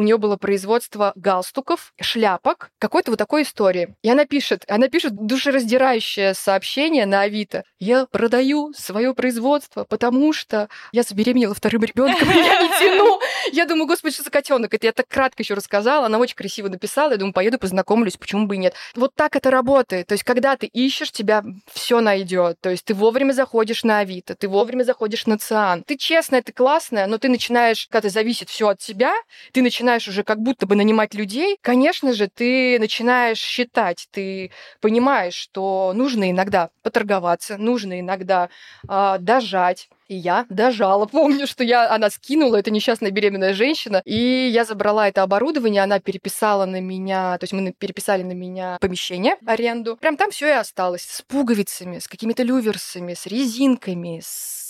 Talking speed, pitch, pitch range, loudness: 175 wpm, 225 Hz, 195-260 Hz, -19 LUFS